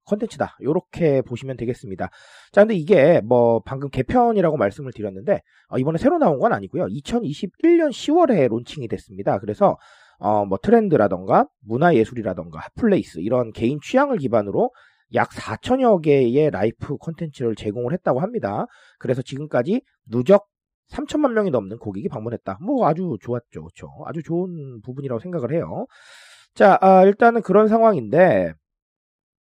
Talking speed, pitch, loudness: 345 characters per minute, 140 Hz, -20 LUFS